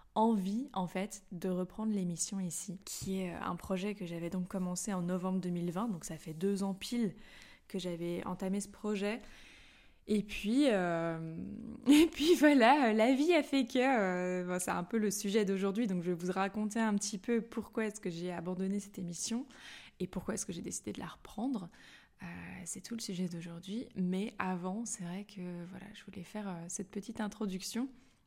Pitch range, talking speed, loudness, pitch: 180-220 Hz, 190 wpm, -35 LUFS, 195 Hz